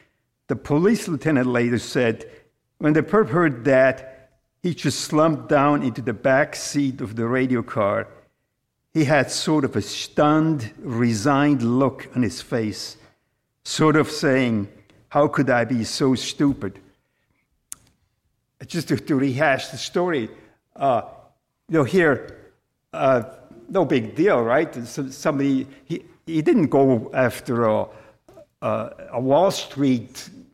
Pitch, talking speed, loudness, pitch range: 135 Hz, 135 wpm, -21 LUFS, 120-150 Hz